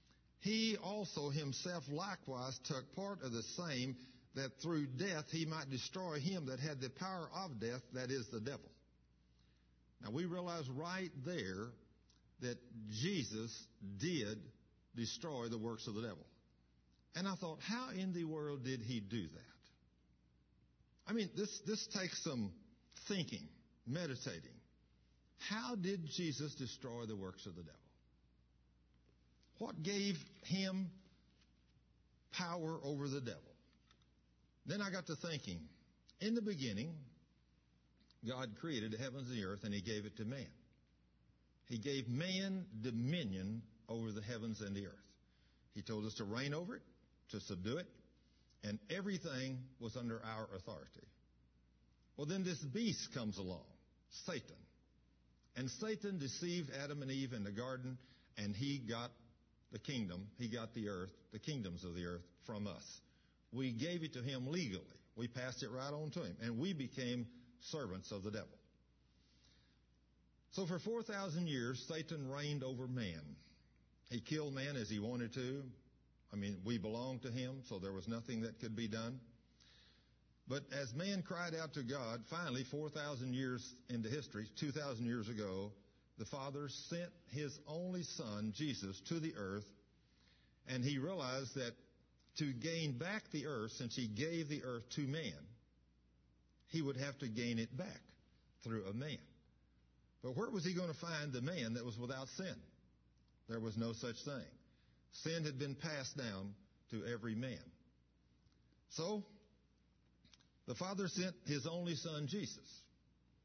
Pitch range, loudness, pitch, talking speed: 90-150 Hz, -45 LUFS, 120 Hz, 150 wpm